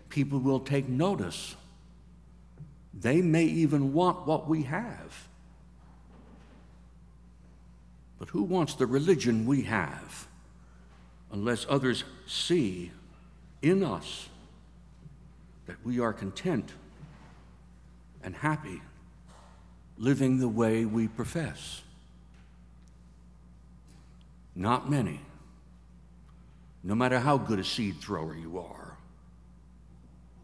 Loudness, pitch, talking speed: -30 LUFS, 80 Hz, 90 wpm